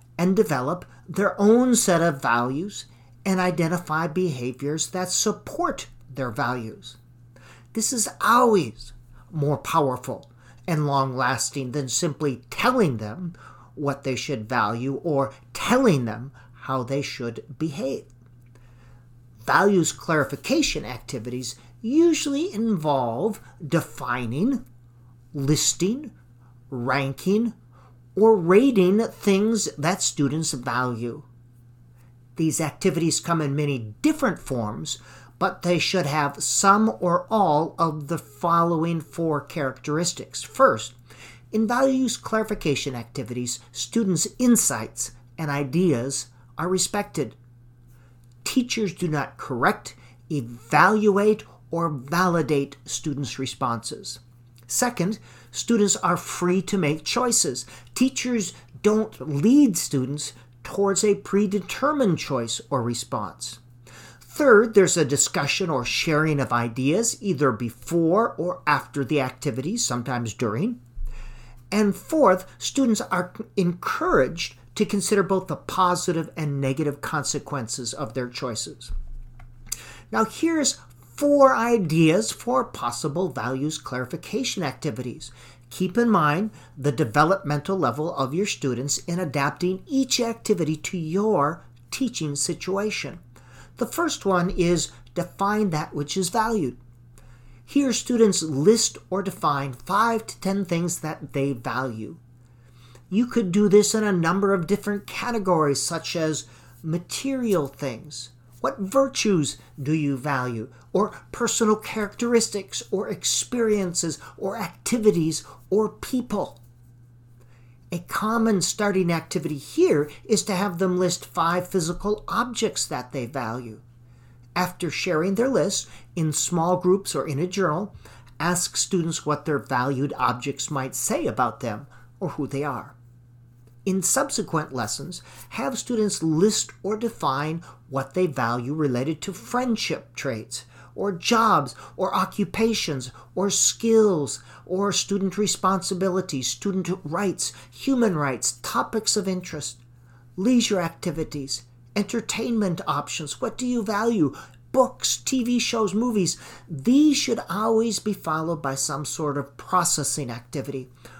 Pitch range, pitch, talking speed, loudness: 125-200 Hz, 155 Hz, 115 wpm, -24 LUFS